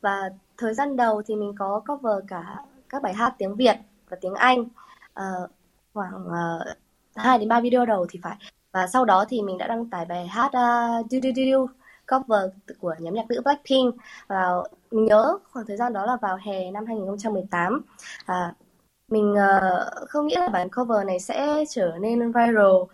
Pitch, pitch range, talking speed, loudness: 215 Hz, 190-250 Hz, 185 wpm, -24 LUFS